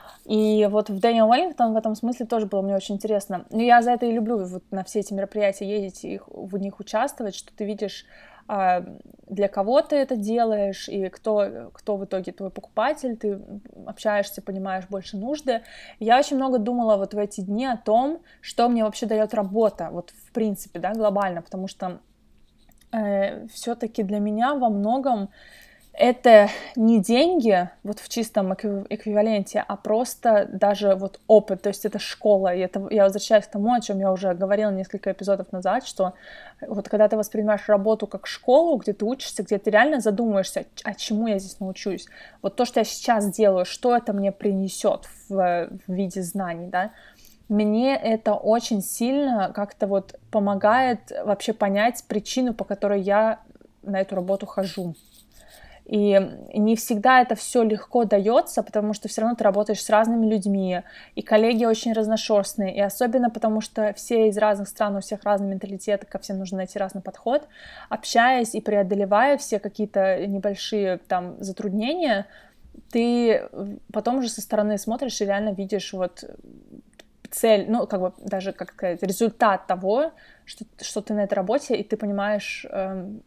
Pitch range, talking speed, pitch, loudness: 195-230 Hz, 170 wpm, 210 Hz, -23 LUFS